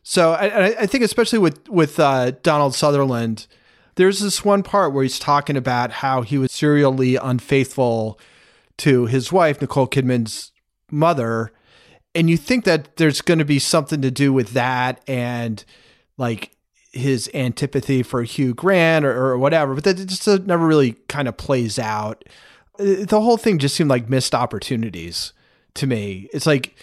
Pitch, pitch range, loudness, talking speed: 135 Hz, 125-165 Hz, -19 LUFS, 165 wpm